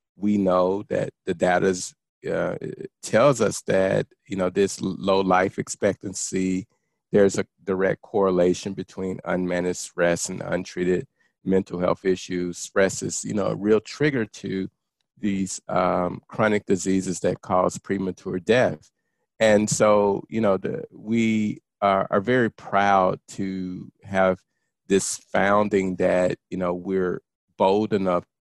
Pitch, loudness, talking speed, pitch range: 95 Hz, -23 LUFS, 135 wpm, 90-100 Hz